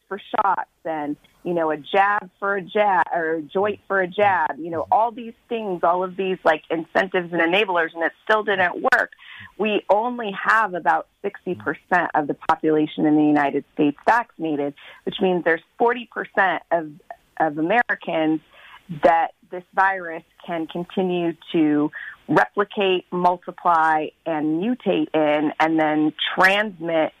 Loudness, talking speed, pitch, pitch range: -21 LUFS, 150 wpm, 175 Hz, 160-200 Hz